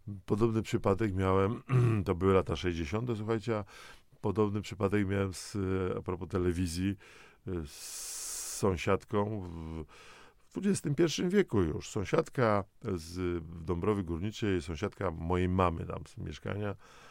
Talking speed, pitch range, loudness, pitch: 110 wpm, 90-110 Hz, -33 LUFS, 100 Hz